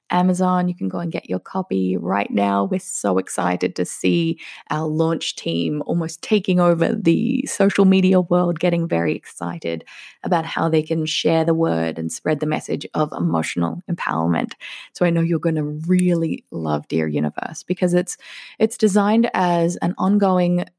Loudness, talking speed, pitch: -20 LUFS, 170 wpm, 165 Hz